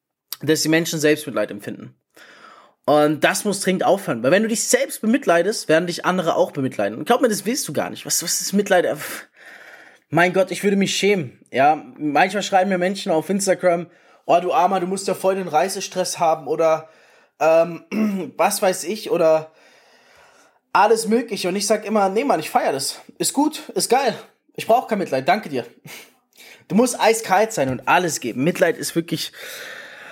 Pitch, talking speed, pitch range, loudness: 185 Hz, 185 wpm, 165-220 Hz, -20 LUFS